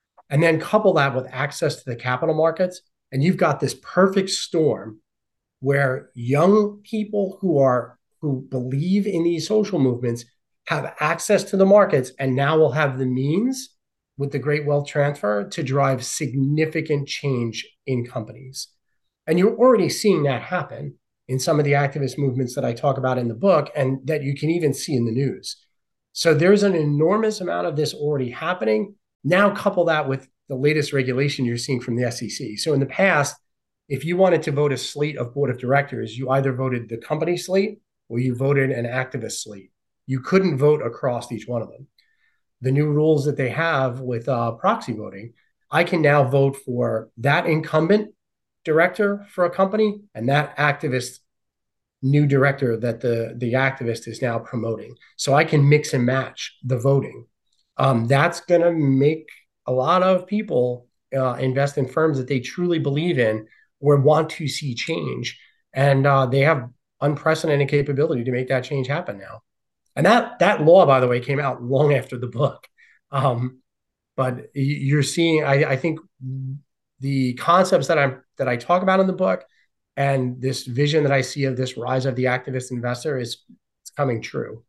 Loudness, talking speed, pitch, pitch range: -21 LUFS, 180 wpm, 140 Hz, 130-160 Hz